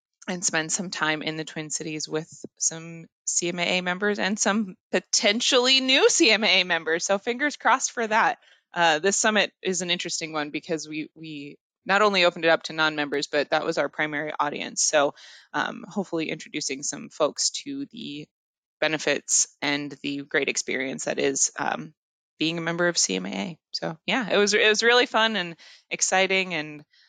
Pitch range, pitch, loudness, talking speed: 155-200 Hz, 165 Hz, -23 LUFS, 175 wpm